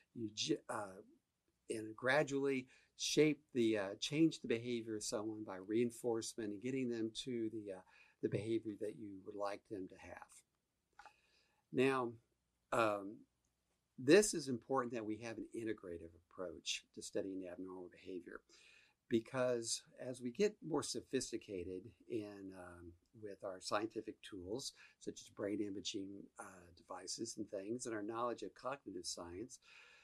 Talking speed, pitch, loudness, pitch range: 140 wpm, 110 Hz, -41 LUFS, 100-125 Hz